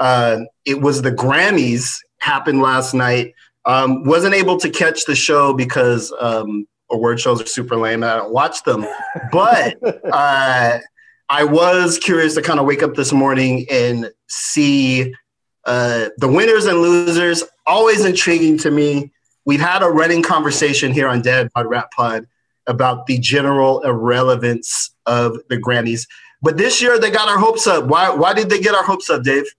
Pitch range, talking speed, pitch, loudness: 120-165 Hz, 170 wpm, 135 Hz, -15 LUFS